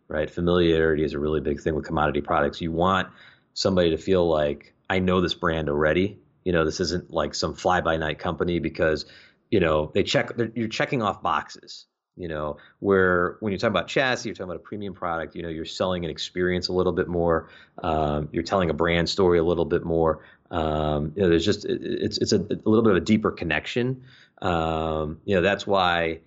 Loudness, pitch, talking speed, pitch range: -24 LUFS, 85 Hz, 215 wpm, 80-90 Hz